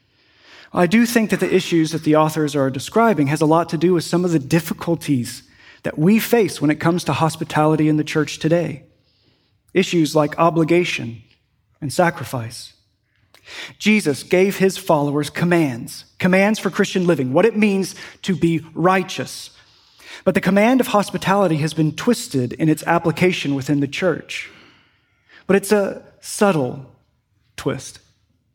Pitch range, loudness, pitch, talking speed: 140-185 Hz, -18 LUFS, 160 Hz, 150 wpm